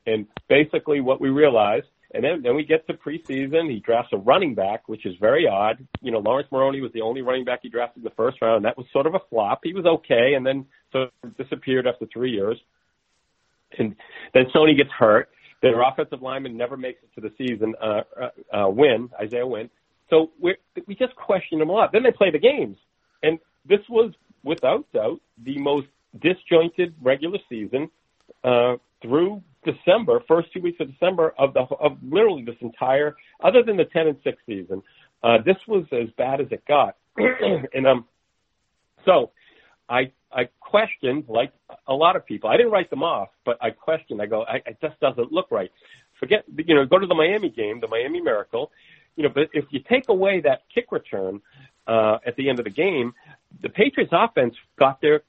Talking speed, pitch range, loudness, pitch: 200 wpm, 130-195 Hz, -22 LUFS, 150 Hz